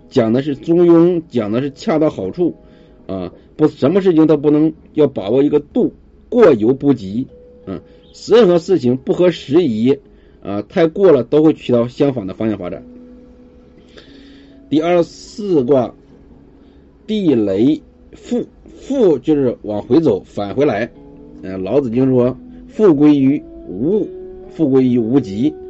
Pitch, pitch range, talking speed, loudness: 150 Hz, 120-195 Hz, 205 characters per minute, -15 LUFS